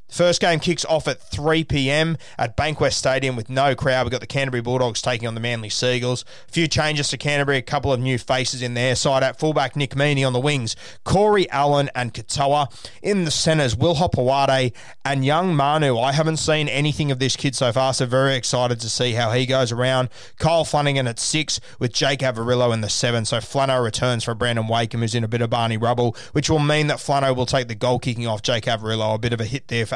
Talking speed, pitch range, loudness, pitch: 230 wpm, 120-145 Hz, -20 LUFS, 130 Hz